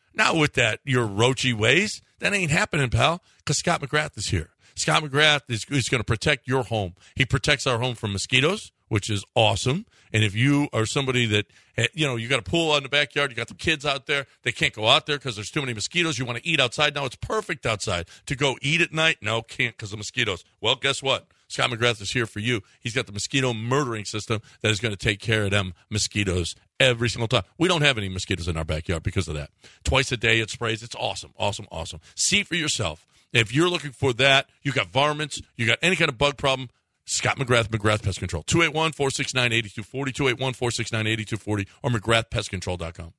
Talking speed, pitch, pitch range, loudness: 220 wpm, 120 Hz, 105-140 Hz, -23 LUFS